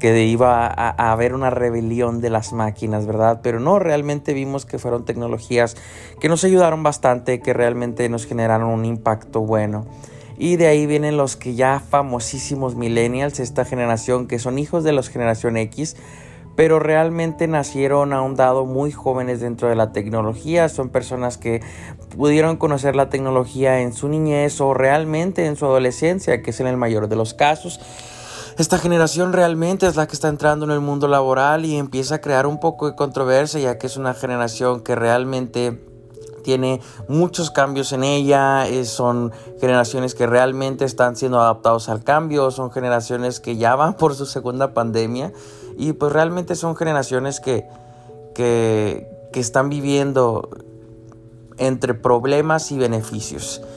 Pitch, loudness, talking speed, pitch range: 130 Hz, -19 LUFS, 165 wpm, 120-145 Hz